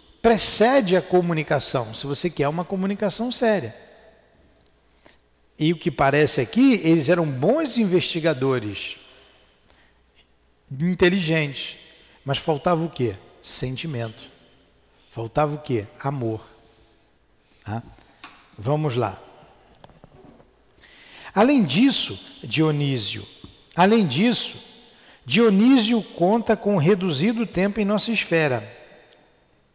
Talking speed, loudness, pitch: 90 wpm, -21 LUFS, 160 Hz